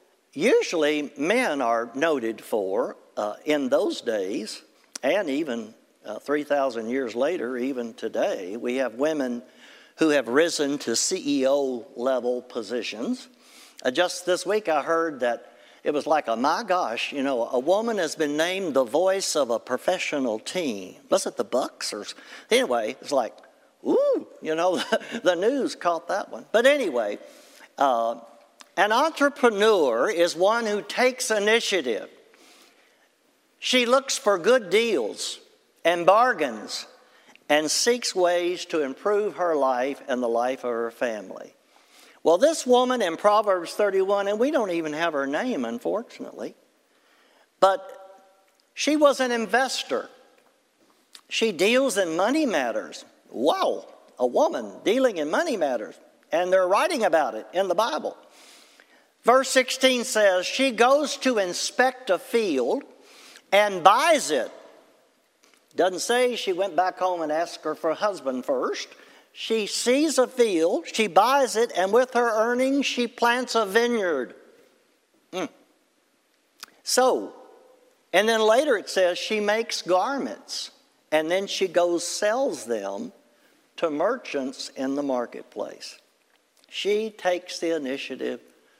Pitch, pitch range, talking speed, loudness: 195 Hz, 155-255 Hz, 140 wpm, -24 LUFS